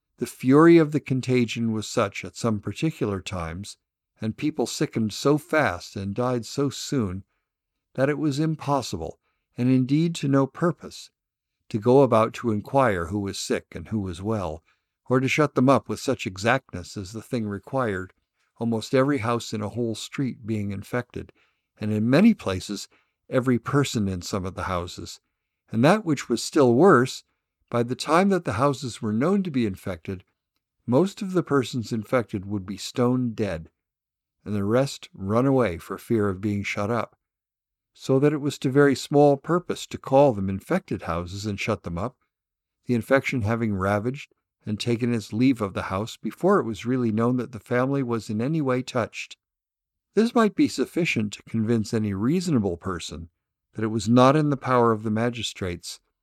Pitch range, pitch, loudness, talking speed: 105-135 Hz, 115 Hz, -24 LUFS, 180 wpm